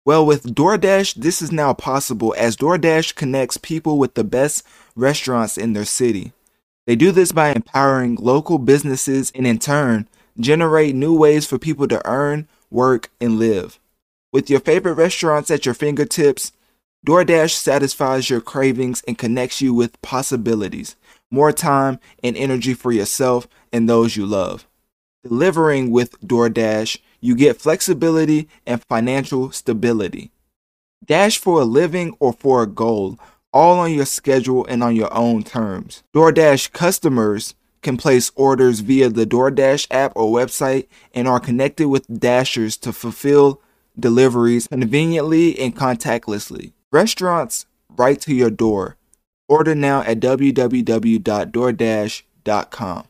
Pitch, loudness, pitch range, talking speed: 130 Hz, -17 LUFS, 120-150 Hz, 135 wpm